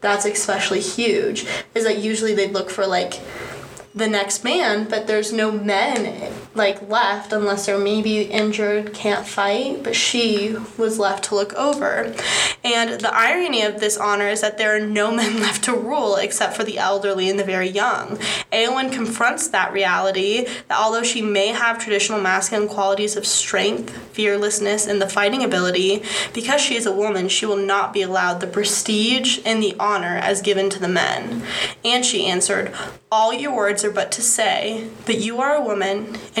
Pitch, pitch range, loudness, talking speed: 210 Hz, 200-225 Hz, -19 LUFS, 185 wpm